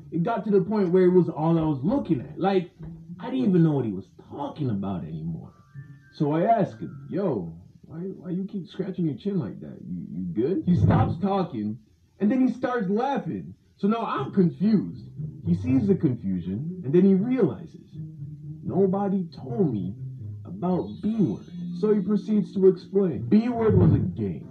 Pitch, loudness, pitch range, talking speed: 175 Hz, -25 LUFS, 150-195 Hz, 190 wpm